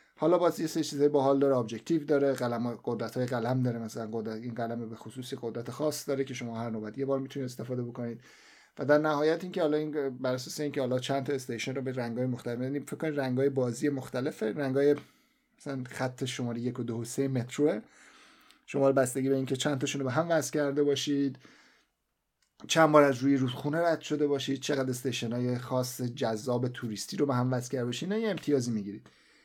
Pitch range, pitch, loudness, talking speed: 120-145 Hz, 135 Hz, -30 LUFS, 210 wpm